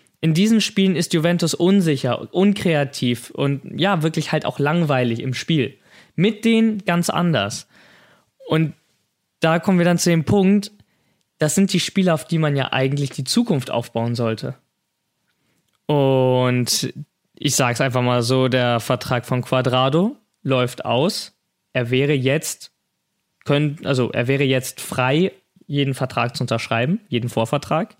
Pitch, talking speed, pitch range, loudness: 145 Hz, 145 wpm, 130-175 Hz, -20 LUFS